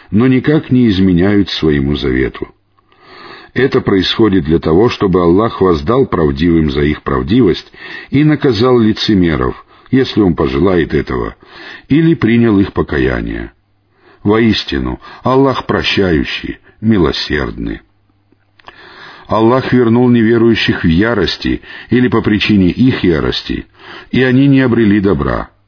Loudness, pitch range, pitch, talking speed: -12 LUFS, 90-125 Hz, 105 Hz, 110 wpm